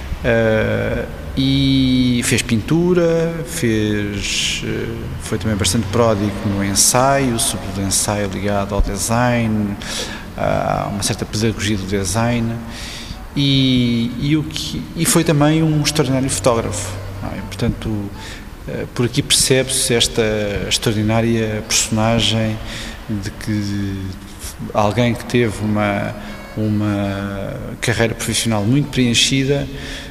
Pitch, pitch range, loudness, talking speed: 110 Hz, 100-125 Hz, -17 LUFS, 110 wpm